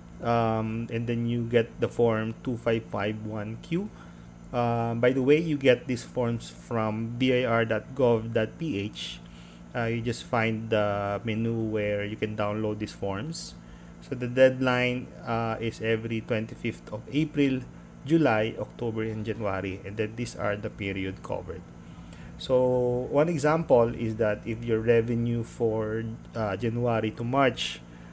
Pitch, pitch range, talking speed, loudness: 115 Hz, 105-120 Hz, 135 wpm, -28 LUFS